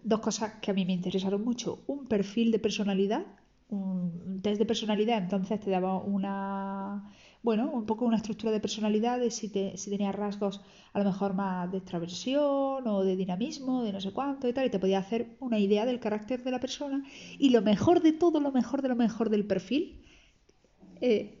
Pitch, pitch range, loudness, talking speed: 215 Hz, 195-240 Hz, -30 LUFS, 200 wpm